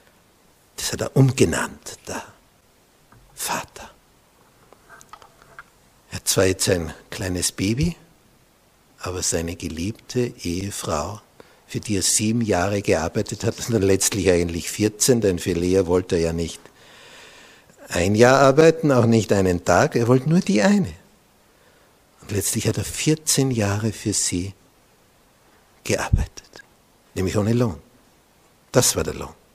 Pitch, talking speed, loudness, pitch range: 105 Hz, 130 wpm, -21 LUFS, 90-125 Hz